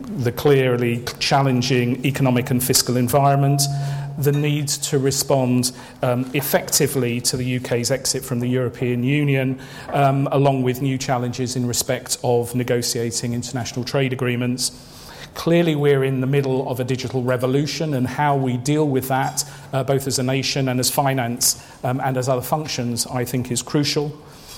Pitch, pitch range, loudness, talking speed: 130 Hz, 125-140 Hz, -20 LUFS, 160 wpm